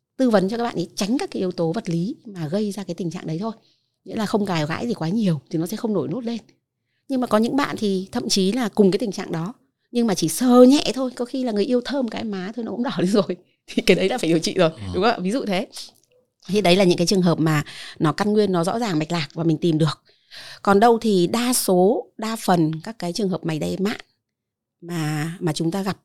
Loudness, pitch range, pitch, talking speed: -21 LUFS, 170-230 Hz, 195 Hz, 280 wpm